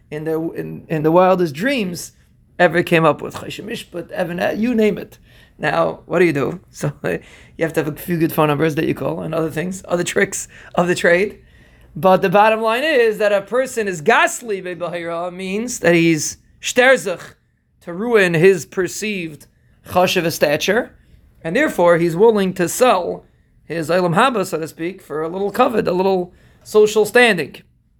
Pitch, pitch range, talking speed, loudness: 175 Hz, 160-210 Hz, 180 wpm, -17 LUFS